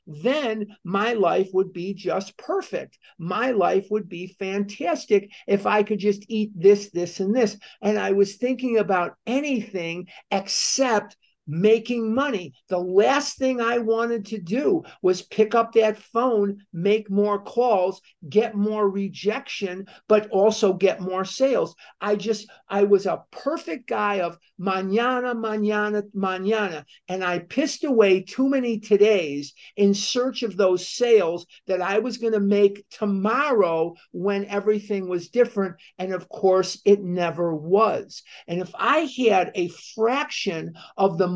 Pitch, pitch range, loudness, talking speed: 205 Hz, 190-230 Hz, -23 LUFS, 145 wpm